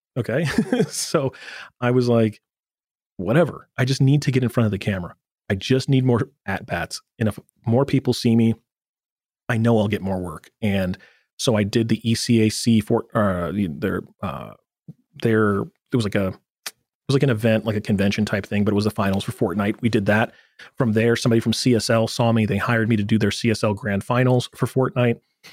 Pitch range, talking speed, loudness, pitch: 105-120 Hz, 205 wpm, -21 LUFS, 115 Hz